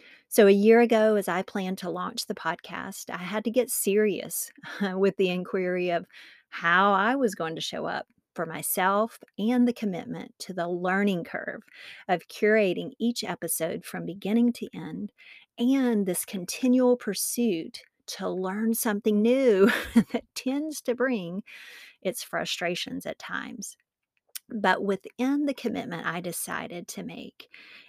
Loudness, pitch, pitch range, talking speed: -27 LUFS, 210 Hz, 185-235 Hz, 145 wpm